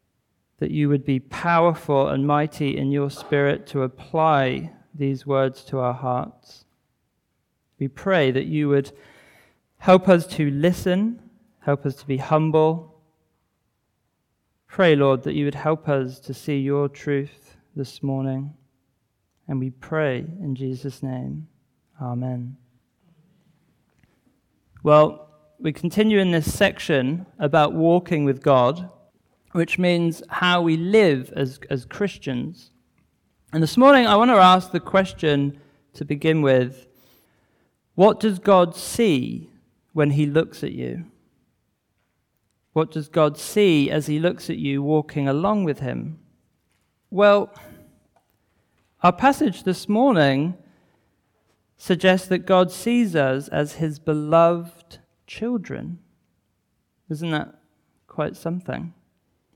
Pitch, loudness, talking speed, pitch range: 150 Hz, -21 LUFS, 120 wpm, 135-175 Hz